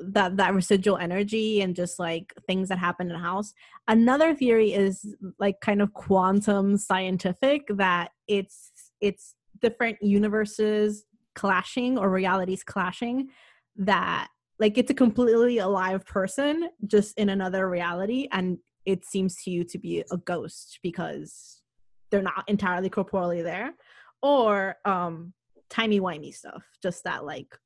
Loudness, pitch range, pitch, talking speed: -26 LUFS, 185-215 Hz, 195 Hz, 140 wpm